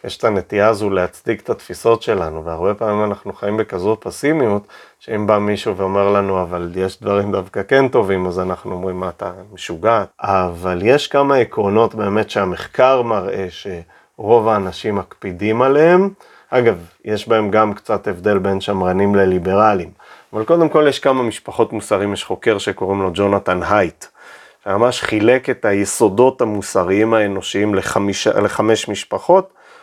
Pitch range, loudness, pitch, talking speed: 95-110 Hz, -17 LUFS, 100 Hz, 145 wpm